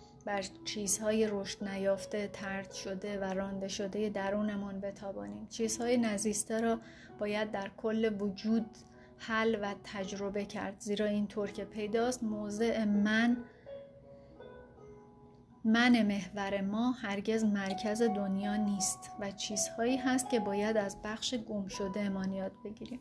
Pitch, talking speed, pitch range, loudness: 205 Hz, 125 wpm, 200-220 Hz, -34 LUFS